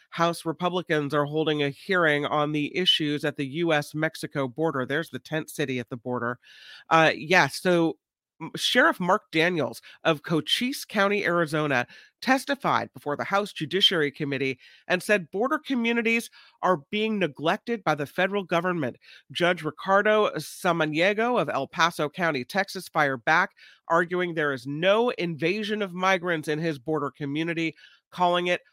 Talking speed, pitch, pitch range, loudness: 145 wpm, 165 Hz, 150-185 Hz, -25 LUFS